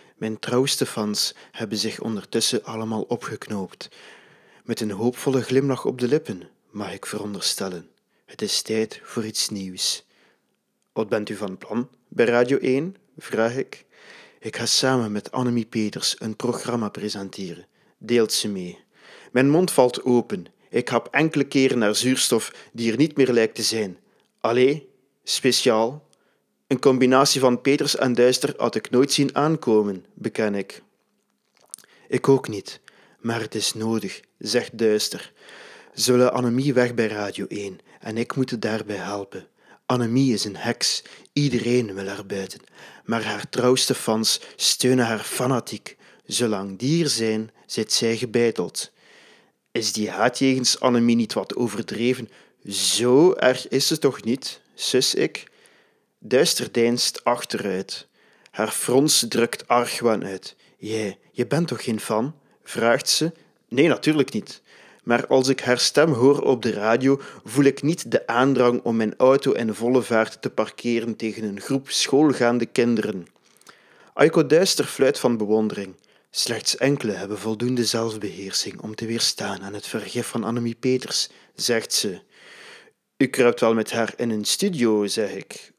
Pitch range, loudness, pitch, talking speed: 110-130 Hz, -22 LUFS, 120 Hz, 150 wpm